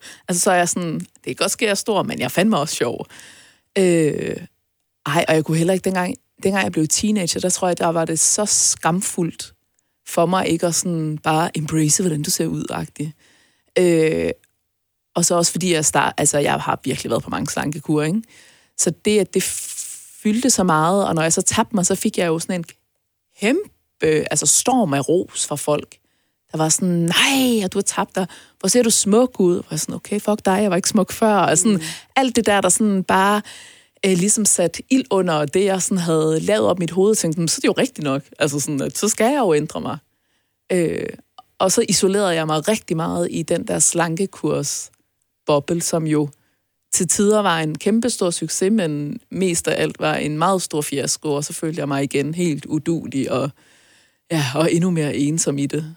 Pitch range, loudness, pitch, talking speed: 155-195 Hz, -19 LUFS, 175 Hz, 215 wpm